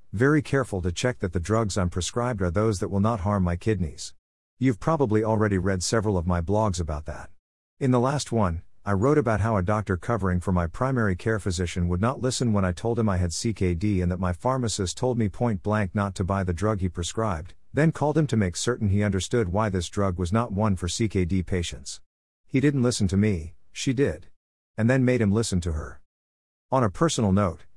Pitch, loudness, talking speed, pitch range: 100 Hz, -25 LUFS, 225 wpm, 90-115 Hz